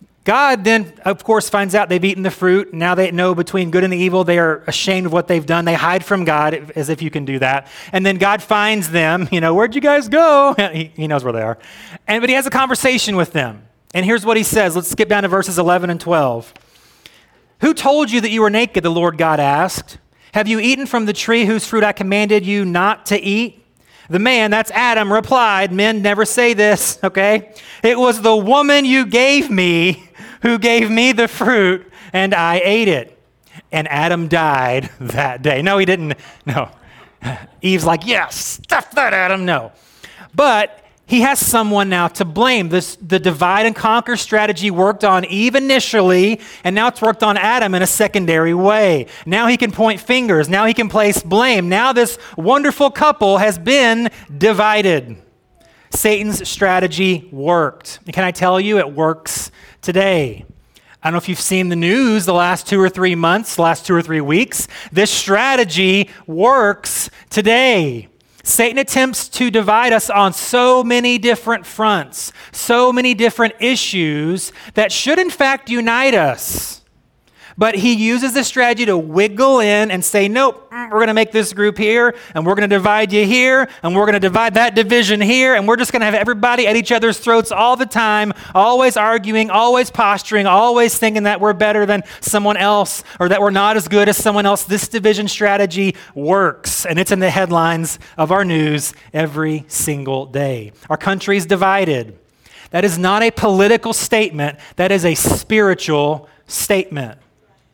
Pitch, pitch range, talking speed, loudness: 205 Hz, 180-225 Hz, 185 wpm, -14 LUFS